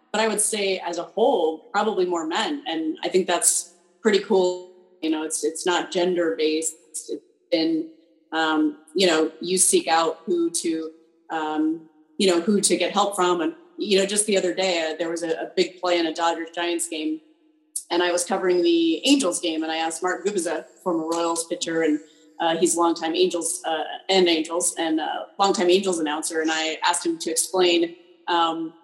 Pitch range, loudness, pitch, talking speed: 160-185 Hz, -23 LUFS, 175 Hz, 205 wpm